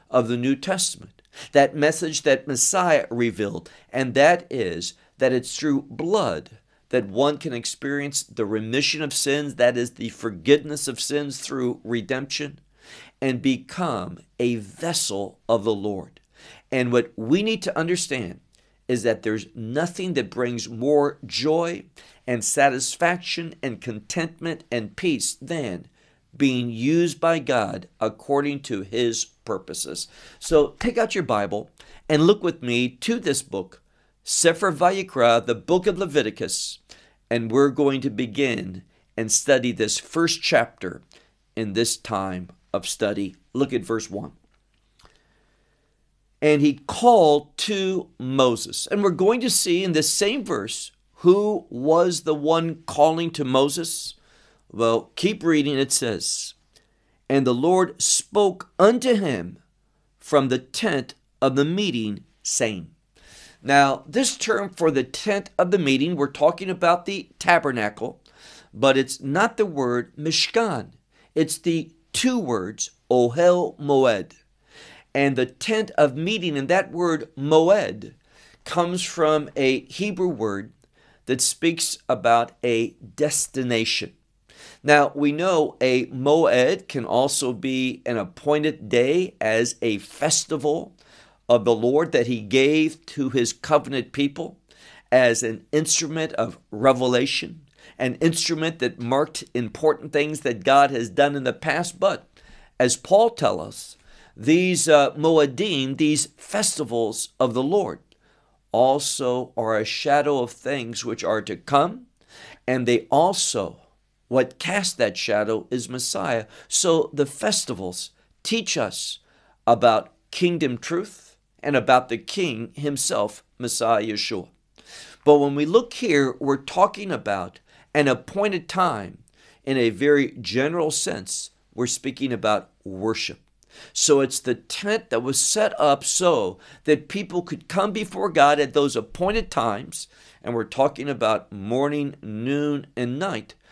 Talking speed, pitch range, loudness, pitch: 135 wpm, 120-165 Hz, -22 LUFS, 140 Hz